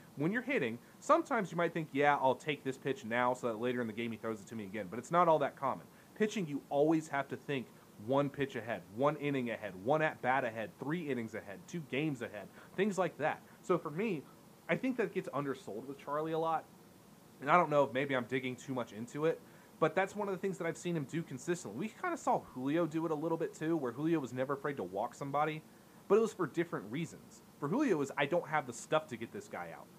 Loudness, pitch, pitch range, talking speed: -36 LUFS, 150 Hz, 130-170 Hz, 260 wpm